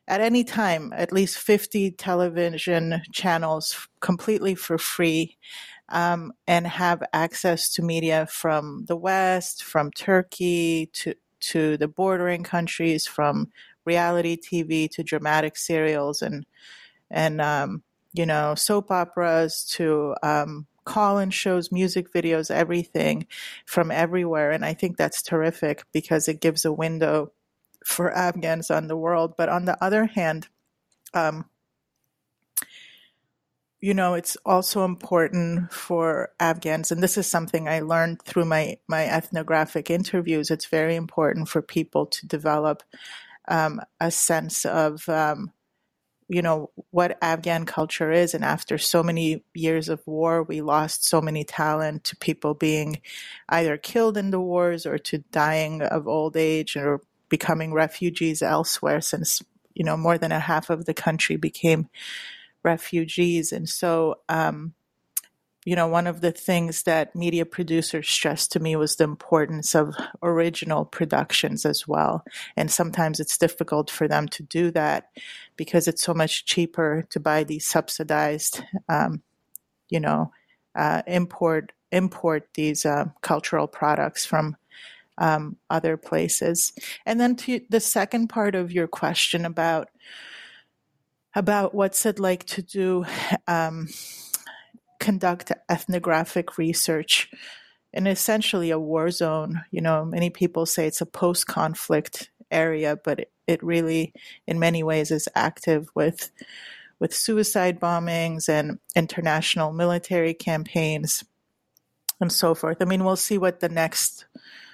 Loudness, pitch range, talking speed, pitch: -24 LUFS, 160-180 Hz, 140 wpm, 165 Hz